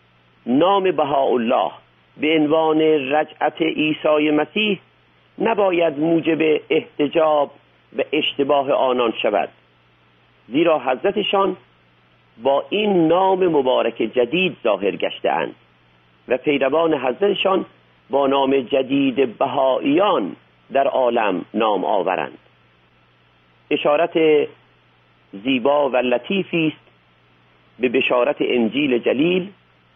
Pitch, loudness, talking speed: 135 Hz, -19 LUFS, 90 wpm